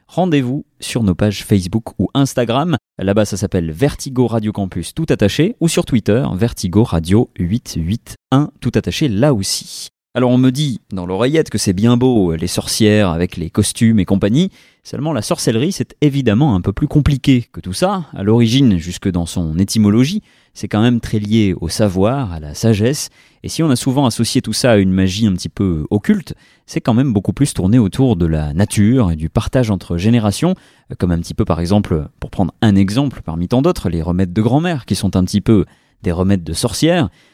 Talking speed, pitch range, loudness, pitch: 205 wpm, 95-130 Hz, -16 LUFS, 110 Hz